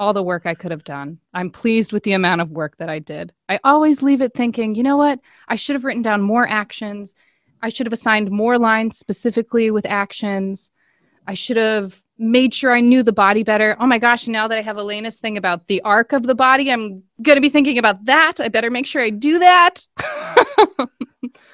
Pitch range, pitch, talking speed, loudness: 200-255 Hz, 225 Hz, 225 wpm, -16 LUFS